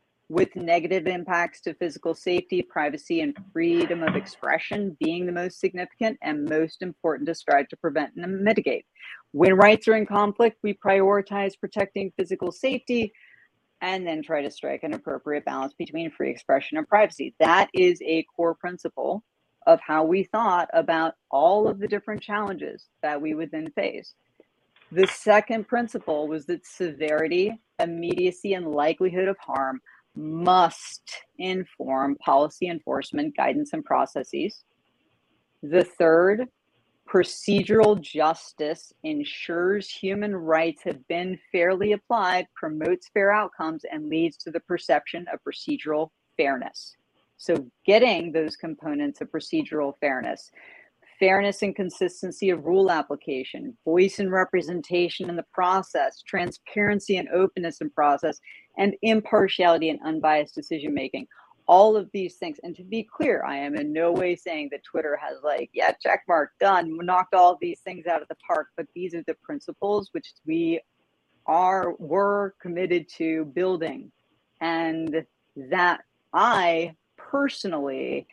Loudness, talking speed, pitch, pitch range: -24 LUFS, 140 wpm, 180 Hz, 165-205 Hz